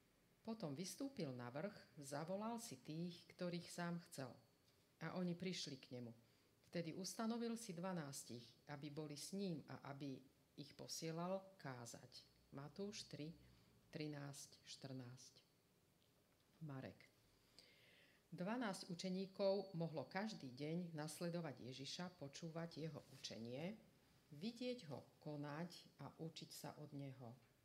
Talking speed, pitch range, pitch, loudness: 110 wpm, 135-180 Hz, 155 Hz, -51 LUFS